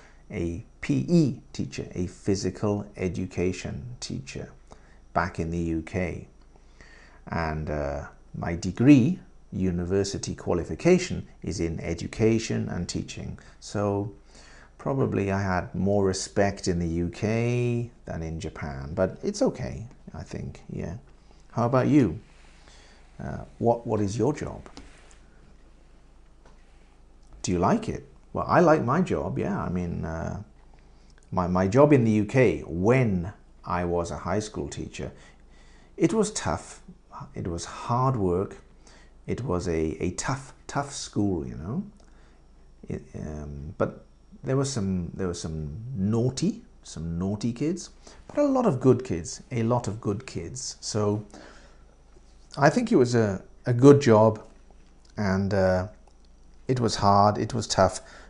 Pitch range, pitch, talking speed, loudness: 85-120 Hz, 100 Hz, 135 wpm, -26 LUFS